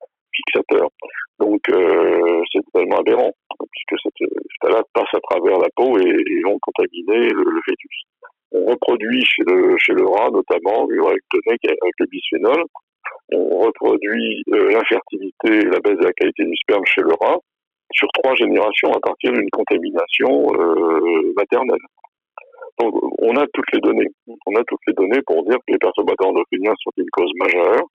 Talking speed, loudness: 165 wpm, -17 LUFS